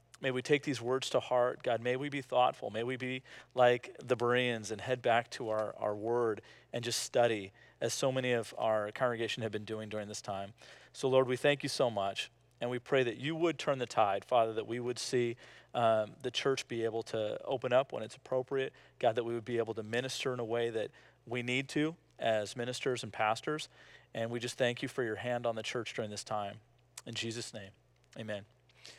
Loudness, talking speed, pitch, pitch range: -34 LUFS, 225 wpm, 120 Hz, 110-125 Hz